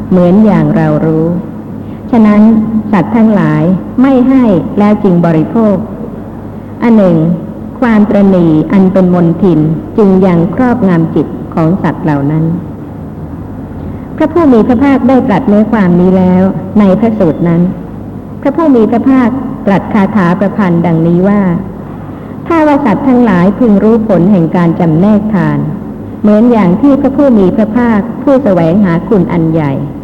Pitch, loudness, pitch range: 200 Hz, -8 LUFS, 175-230 Hz